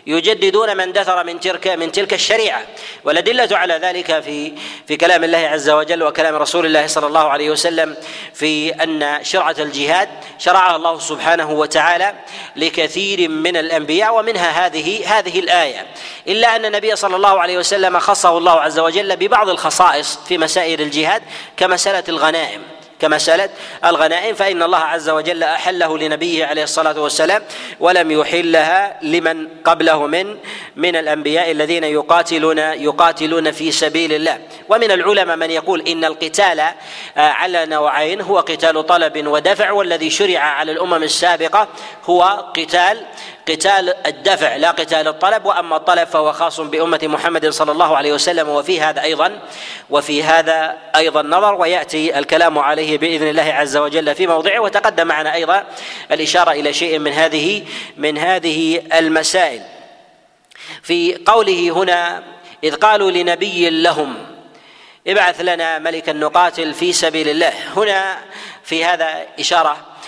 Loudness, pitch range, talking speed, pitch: -15 LUFS, 155-185 Hz, 135 wpm, 165 Hz